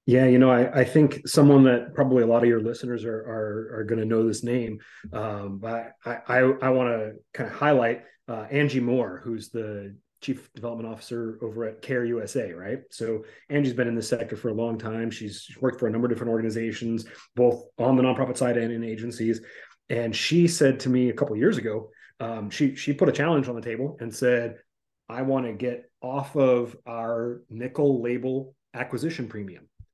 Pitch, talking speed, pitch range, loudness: 120 Hz, 205 wpm, 115-130 Hz, -25 LUFS